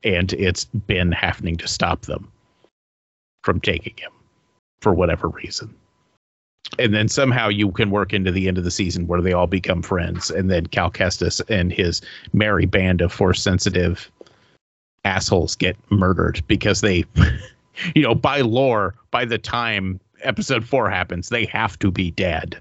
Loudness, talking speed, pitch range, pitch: -20 LUFS, 160 wpm, 90-105 Hz, 95 Hz